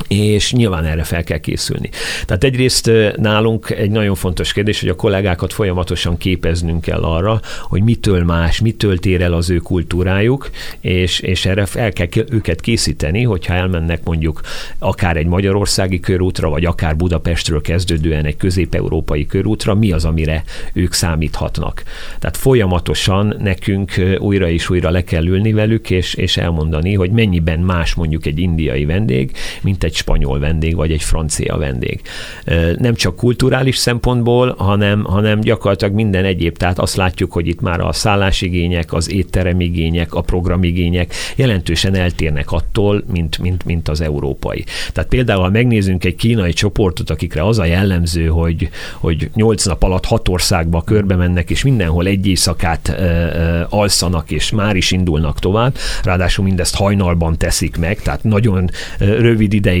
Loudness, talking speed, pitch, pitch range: -15 LUFS, 155 wpm, 90 Hz, 85-105 Hz